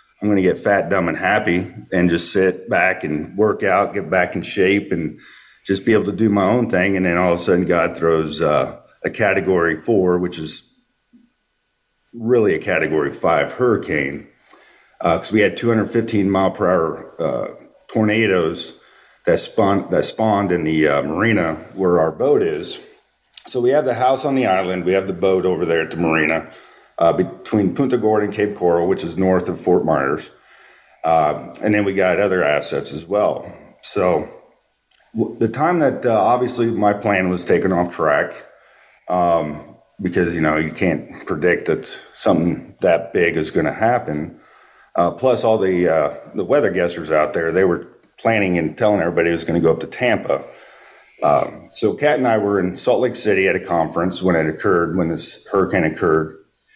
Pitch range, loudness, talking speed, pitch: 85-105 Hz, -18 LUFS, 190 wpm, 95 Hz